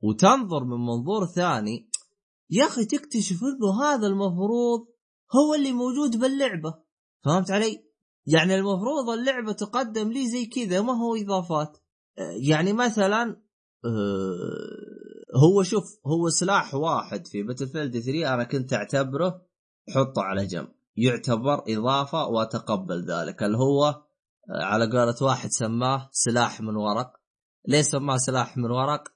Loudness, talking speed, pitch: -25 LUFS, 125 wpm, 155 Hz